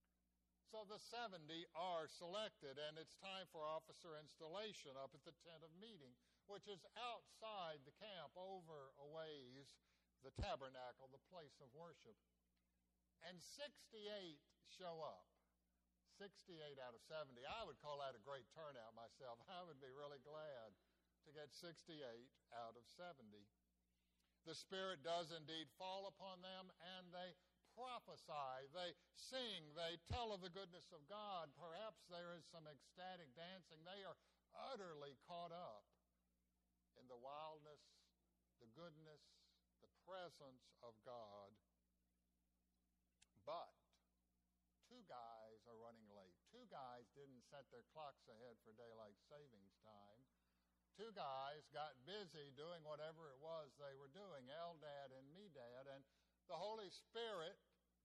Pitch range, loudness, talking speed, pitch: 110-175 Hz, -57 LUFS, 135 wpm, 150 Hz